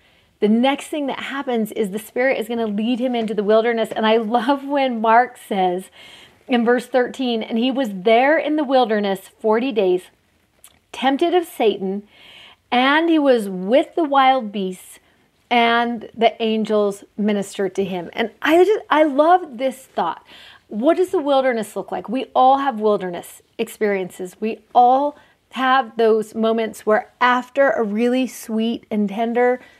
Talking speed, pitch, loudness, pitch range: 160 wpm, 235 Hz, -19 LUFS, 215-265 Hz